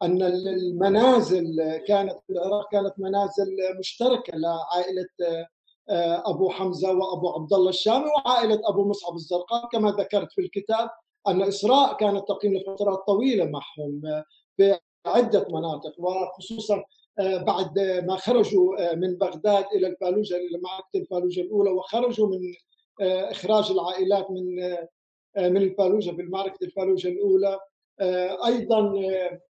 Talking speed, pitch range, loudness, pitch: 115 wpm, 180-205 Hz, -24 LUFS, 190 Hz